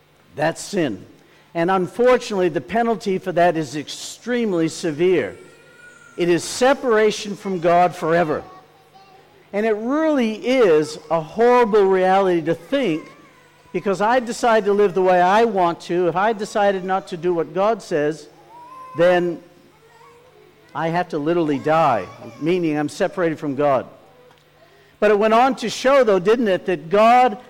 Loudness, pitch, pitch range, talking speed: -19 LUFS, 185 Hz, 170-225 Hz, 145 wpm